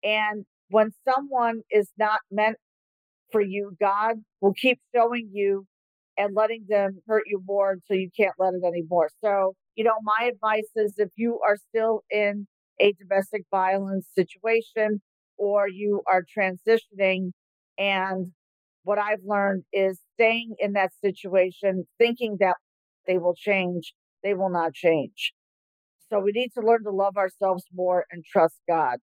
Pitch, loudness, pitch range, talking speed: 200 Hz, -25 LUFS, 190-215 Hz, 155 wpm